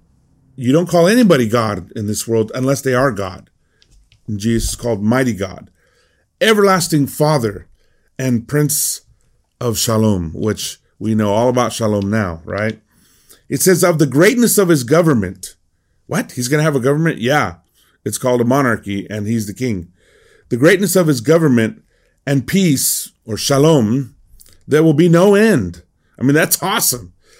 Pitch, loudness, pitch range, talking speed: 125 Hz, -15 LUFS, 105-150 Hz, 160 wpm